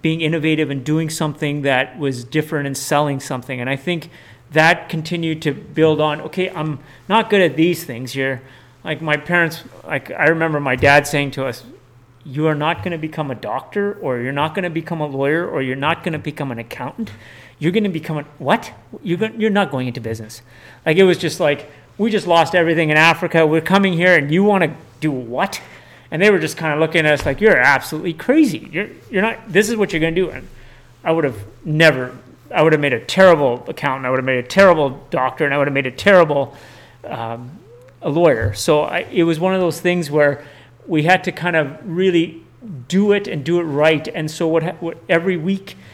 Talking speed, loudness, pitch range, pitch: 225 wpm, -17 LUFS, 135-170 Hz, 155 Hz